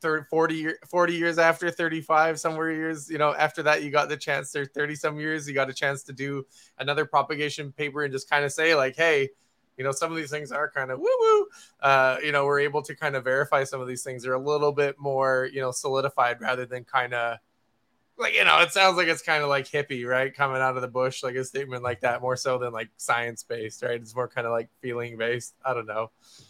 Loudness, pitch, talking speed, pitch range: -25 LUFS, 140 Hz, 250 wpm, 130-155 Hz